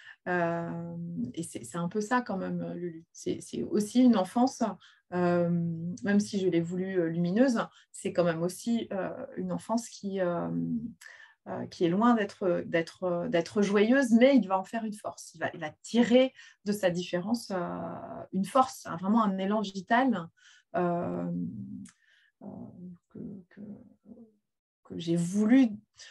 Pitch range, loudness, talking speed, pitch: 175-230 Hz, -29 LUFS, 155 wpm, 195 Hz